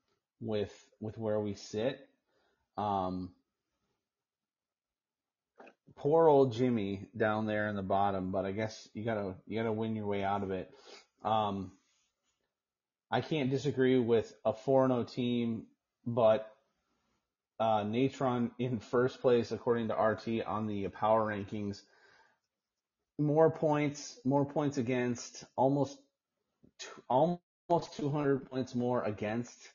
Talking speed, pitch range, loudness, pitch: 120 wpm, 105-130 Hz, -33 LUFS, 115 Hz